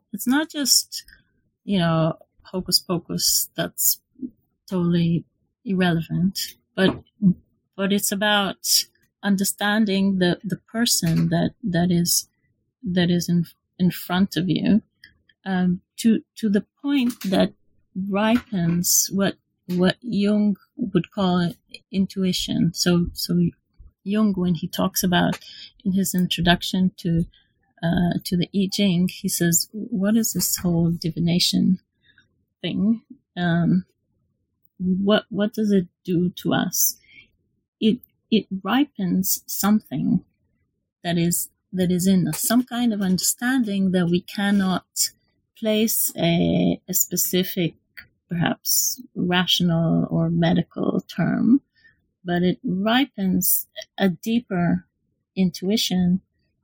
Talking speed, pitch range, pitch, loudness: 110 wpm, 175-210 Hz, 185 Hz, -22 LUFS